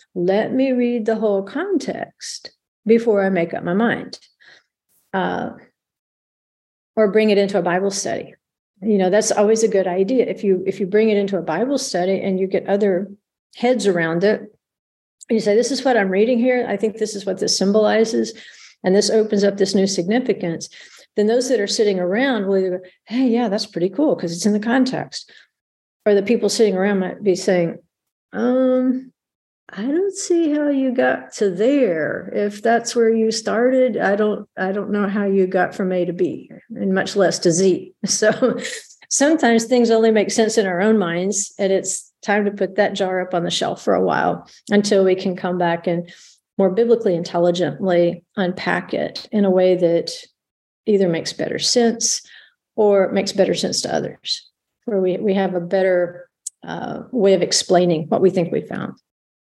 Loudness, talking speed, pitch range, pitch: -19 LUFS, 190 wpm, 185-230 Hz, 205 Hz